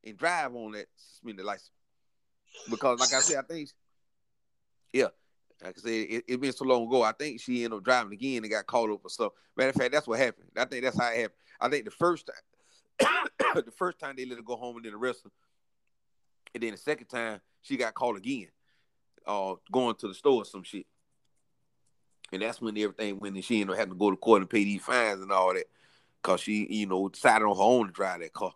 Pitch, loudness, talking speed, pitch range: 120 Hz, -29 LUFS, 245 wpm, 105-135 Hz